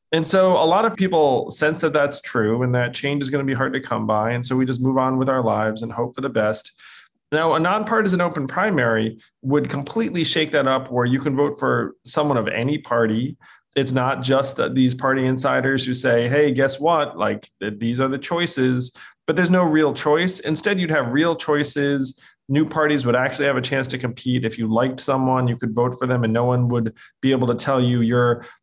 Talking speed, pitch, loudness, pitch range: 230 wpm, 135 Hz, -20 LUFS, 120-150 Hz